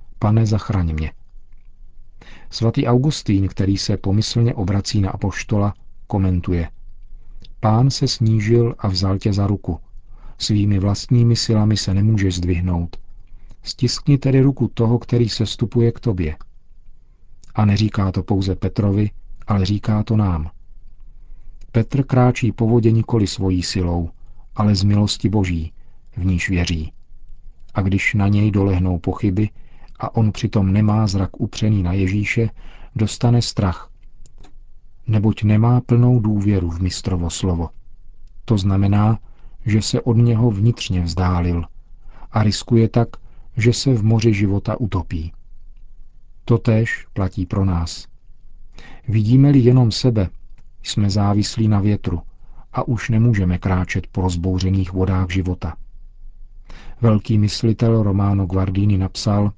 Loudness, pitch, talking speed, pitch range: -19 LUFS, 105 Hz, 125 wpm, 95-115 Hz